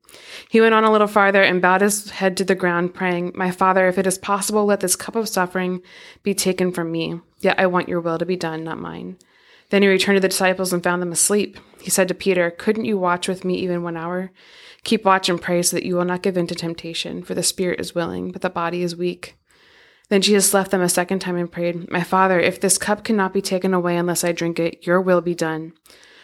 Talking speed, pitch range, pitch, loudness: 250 wpm, 175-195 Hz, 180 Hz, -19 LUFS